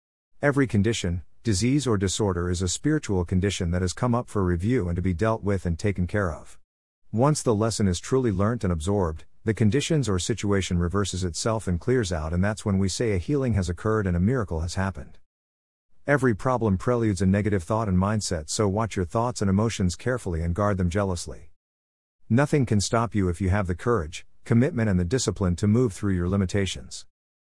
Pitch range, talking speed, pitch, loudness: 90-115 Hz, 200 wpm, 100 Hz, -25 LUFS